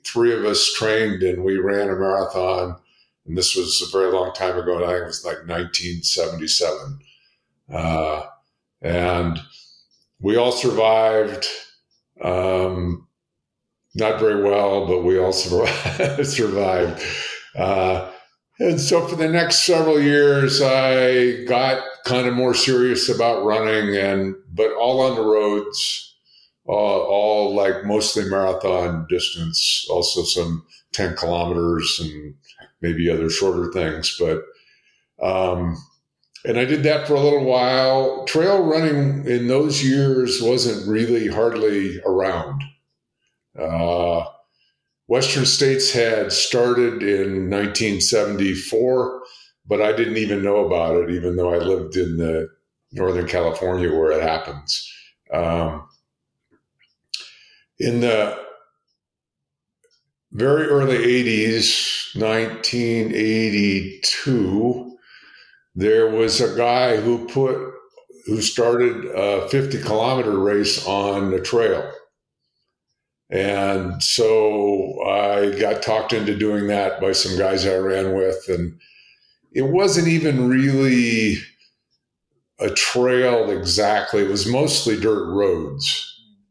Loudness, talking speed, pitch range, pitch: -19 LUFS, 115 wpm, 95-130 Hz, 110 Hz